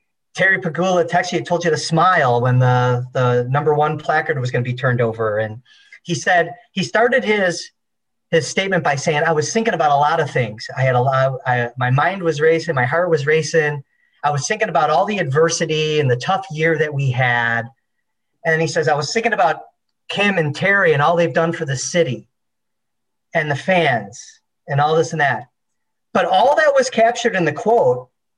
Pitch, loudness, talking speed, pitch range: 160 Hz, -17 LUFS, 205 wpm, 130-175 Hz